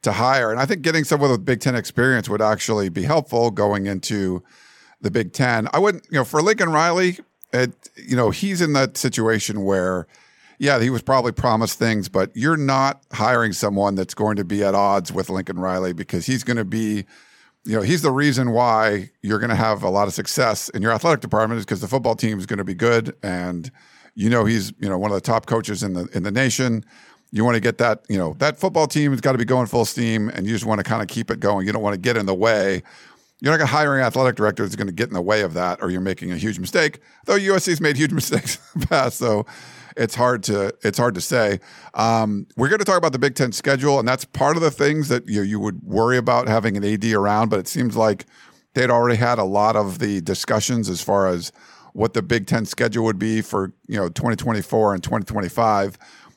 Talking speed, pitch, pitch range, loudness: 245 wpm, 115 Hz, 105-130 Hz, -20 LUFS